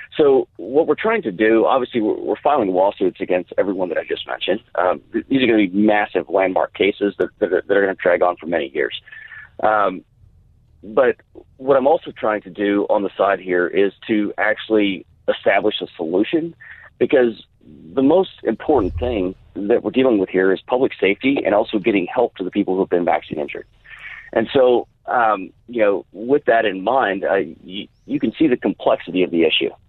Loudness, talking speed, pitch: -19 LUFS, 200 wpm, 110 Hz